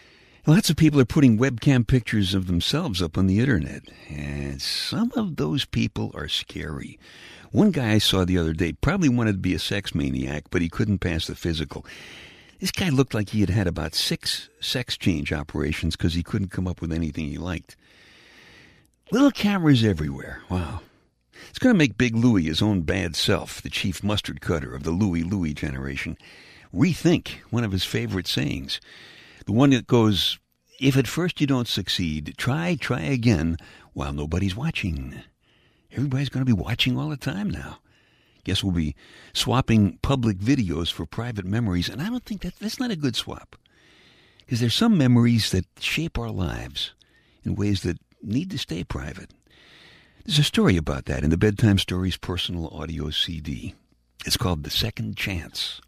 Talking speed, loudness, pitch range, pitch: 180 wpm, -24 LUFS, 85-125 Hz, 100 Hz